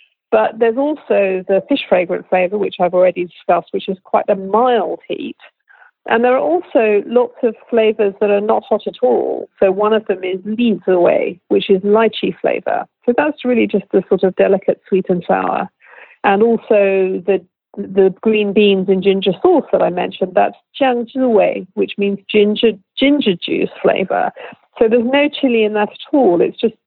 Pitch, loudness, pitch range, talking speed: 210 Hz, -15 LUFS, 195-240 Hz, 185 wpm